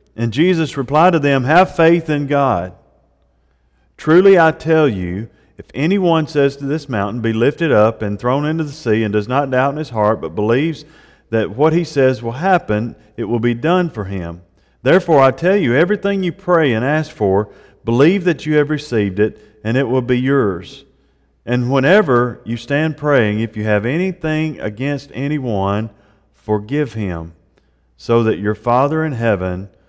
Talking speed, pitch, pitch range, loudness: 175 wpm, 125 Hz, 105-155 Hz, -16 LUFS